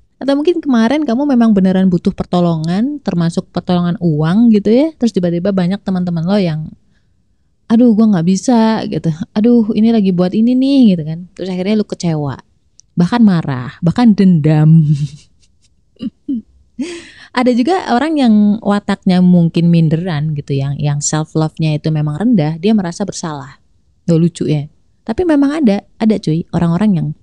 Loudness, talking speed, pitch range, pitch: -13 LUFS, 150 wpm, 165-225 Hz, 185 Hz